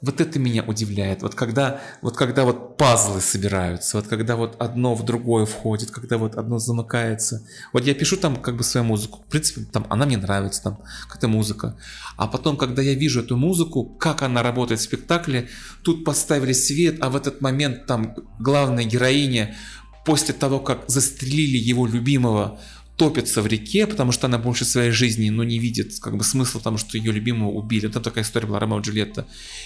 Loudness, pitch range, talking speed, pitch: -21 LUFS, 110-135 Hz, 195 wpm, 120 Hz